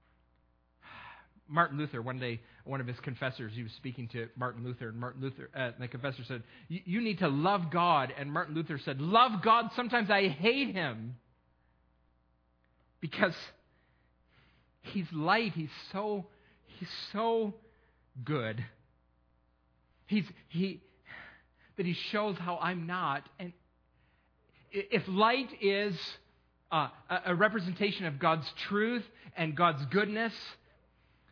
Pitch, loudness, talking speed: 150 Hz, -32 LUFS, 130 wpm